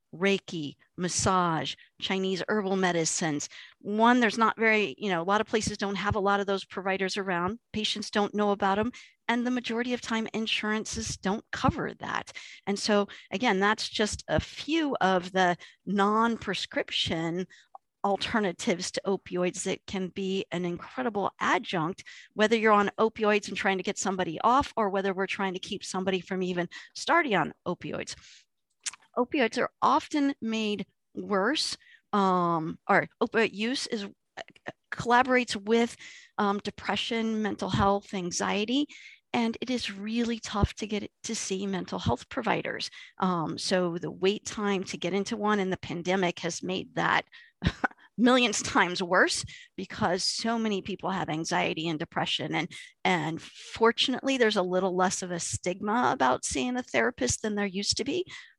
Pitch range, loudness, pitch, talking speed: 185-225 Hz, -28 LUFS, 200 Hz, 160 wpm